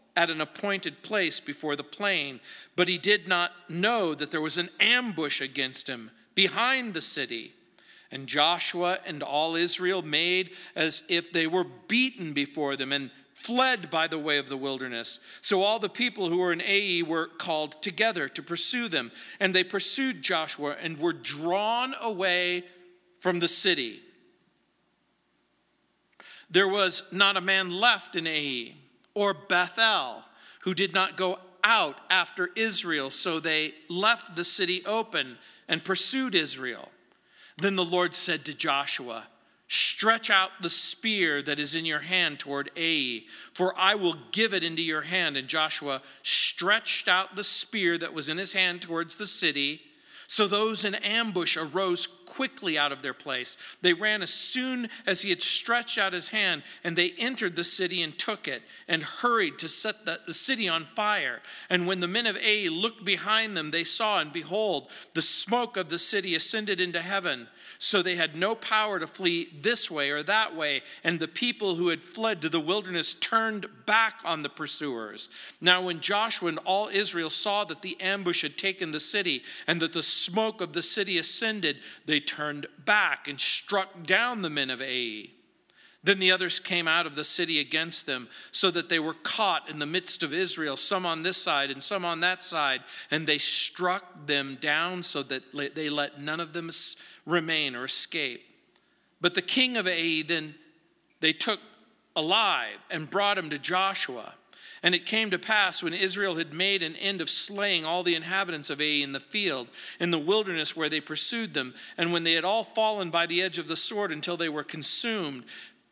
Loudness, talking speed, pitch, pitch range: -26 LUFS, 180 wpm, 175 Hz, 160-200 Hz